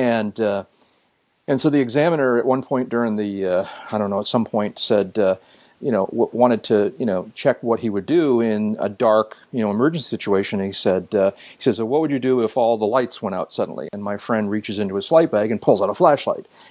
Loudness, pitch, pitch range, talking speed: -20 LUFS, 110 Hz, 100-125 Hz, 250 wpm